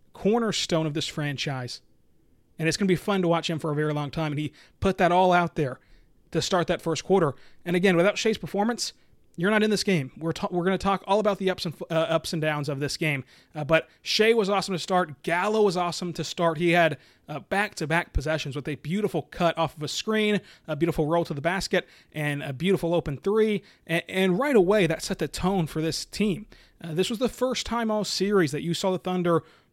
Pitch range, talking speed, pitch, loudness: 160-195 Hz, 240 wpm, 170 Hz, -26 LUFS